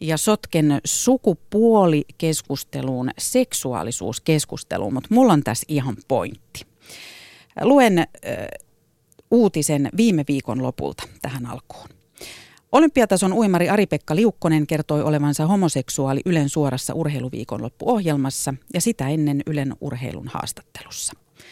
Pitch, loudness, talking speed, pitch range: 155 Hz, -21 LUFS, 100 wpm, 140-205 Hz